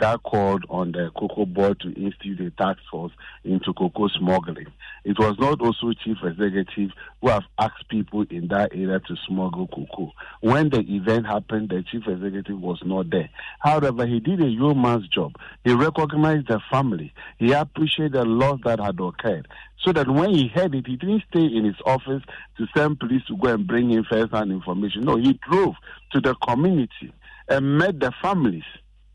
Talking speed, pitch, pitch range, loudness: 185 wpm, 110 Hz, 100-135 Hz, -23 LUFS